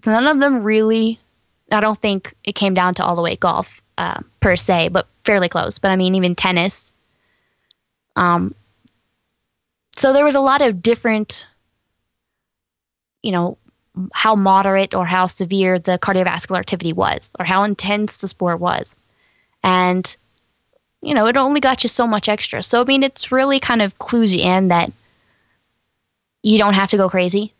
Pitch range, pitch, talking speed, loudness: 185-230 Hz, 205 Hz, 170 wpm, -16 LUFS